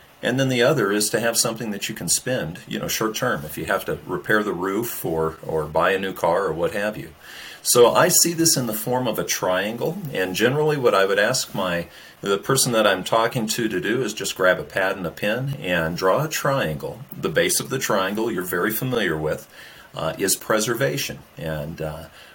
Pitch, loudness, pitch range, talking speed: 105 Hz, -21 LUFS, 80-125 Hz, 225 wpm